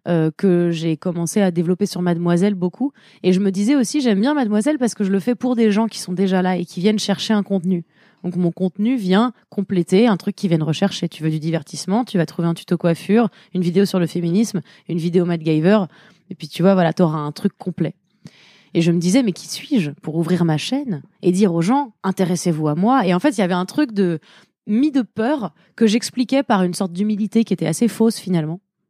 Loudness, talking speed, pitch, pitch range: -19 LUFS, 240 wpm, 190 Hz, 175-215 Hz